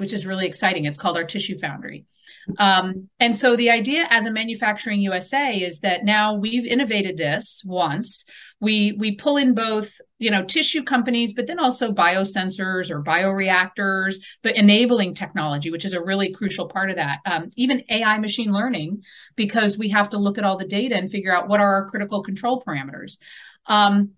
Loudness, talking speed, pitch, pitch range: -20 LUFS, 185 wpm, 205 Hz, 190-225 Hz